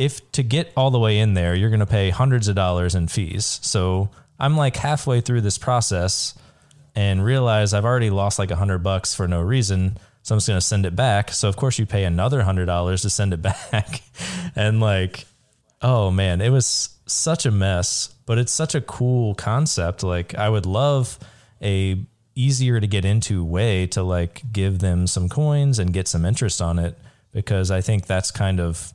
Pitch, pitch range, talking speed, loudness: 105 Hz, 95-125 Hz, 200 wpm, -21 LUFS